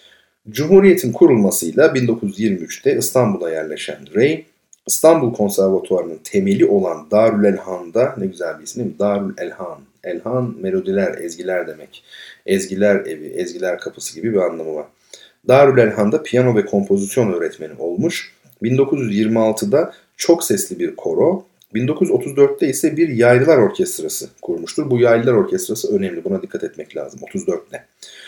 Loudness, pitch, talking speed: -17 LUFS, 120 Hz, 125 wpm